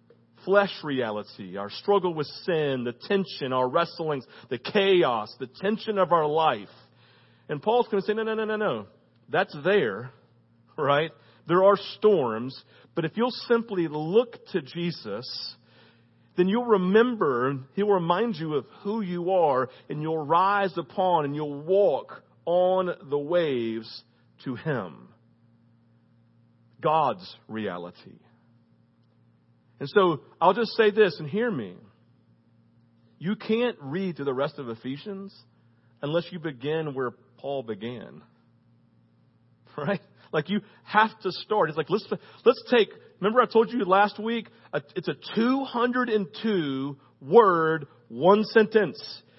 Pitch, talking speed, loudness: 155 Hz, 135 wpm, -26 LUFS